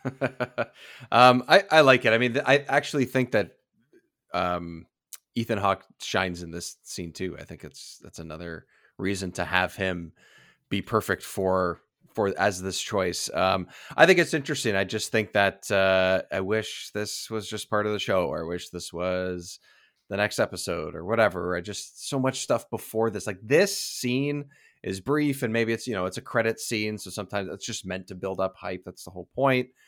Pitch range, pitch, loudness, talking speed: 90-125 Hz, 100 Hz, -26 LUFS, 195 wpm